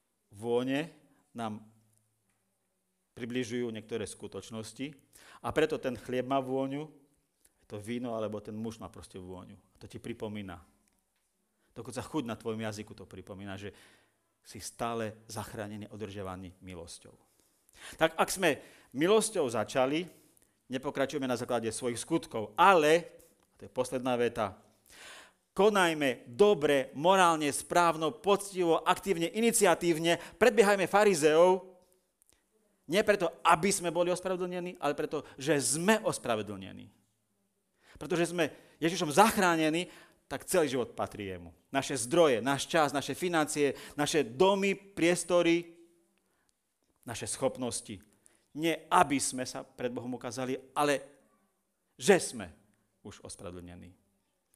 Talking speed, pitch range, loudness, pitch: 115 wpm, 110-170 Hz, -30 LUFS, 135 Hz